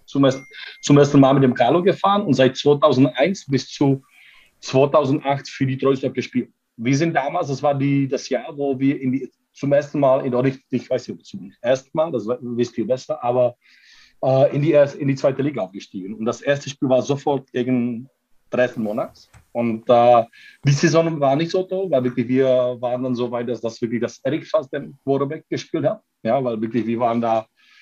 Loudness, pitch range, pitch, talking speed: -20 LUFS, 125-140 Hz, 135 Hz, 205 wpm